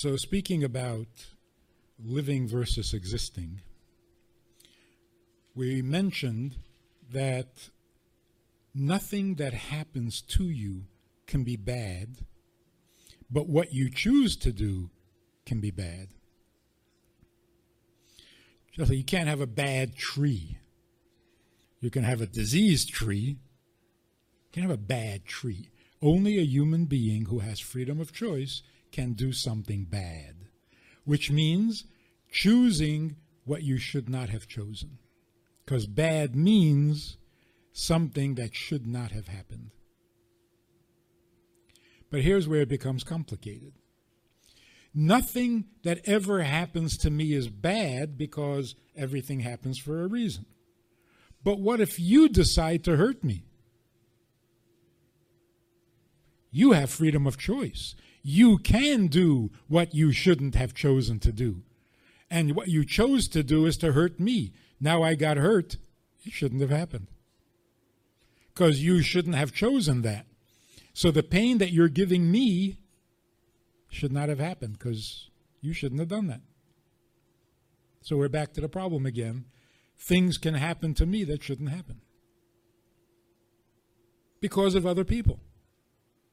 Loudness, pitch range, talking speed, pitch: -27 LUFS, 115-165 Hz, 125 wpm, 135 Hz